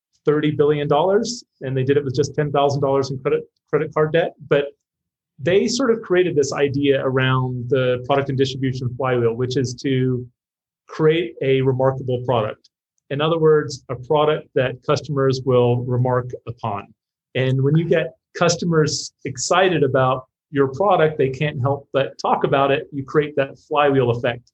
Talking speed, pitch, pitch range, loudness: 160 wpm, 140 Hz, 130-150 Hz, -20 LUFS